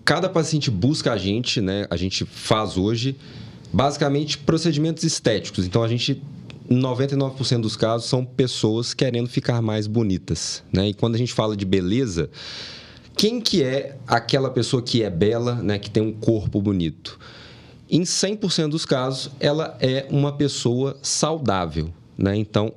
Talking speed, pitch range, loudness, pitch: 155 wpm, 110-145 Hz, -22 LUFS, 125 Hz